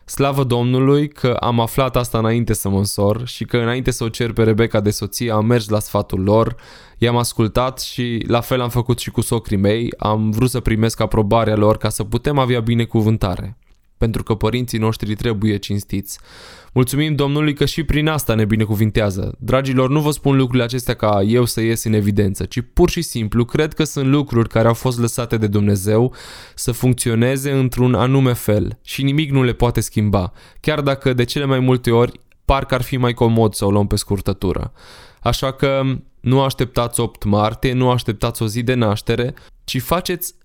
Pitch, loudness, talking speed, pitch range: 120 Hz, -18 LUFS, 190 wpm, 110-130 Hz